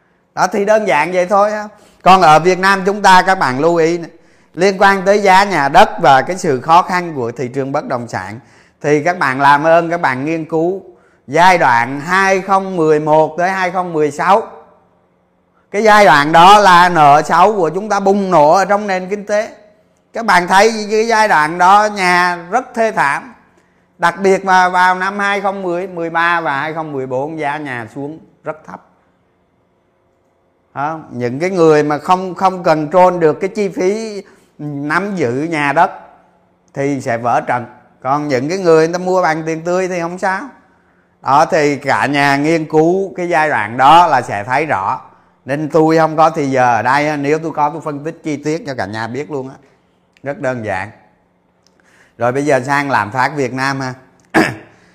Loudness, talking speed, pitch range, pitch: -13 LUFS, 185 wpm, 140-185 Hz, 160 Hz